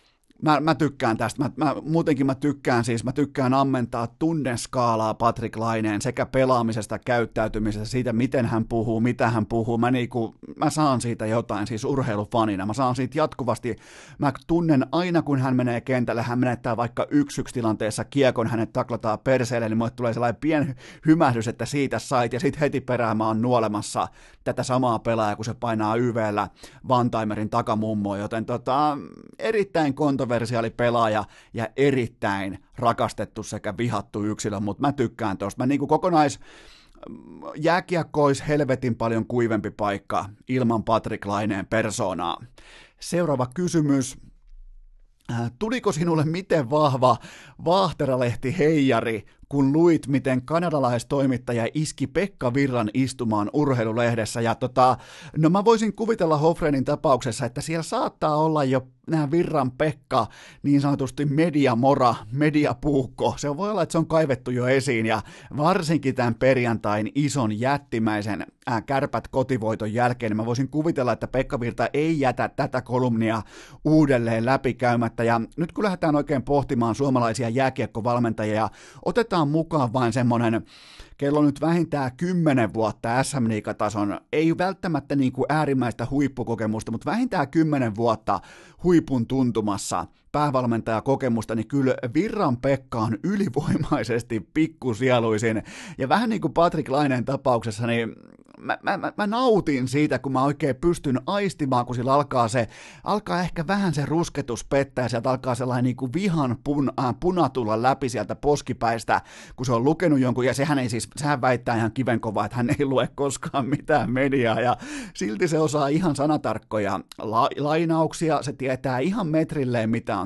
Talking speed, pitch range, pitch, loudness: 145 wpm, 115-150 Hz, 130 Hz, -24 LUFS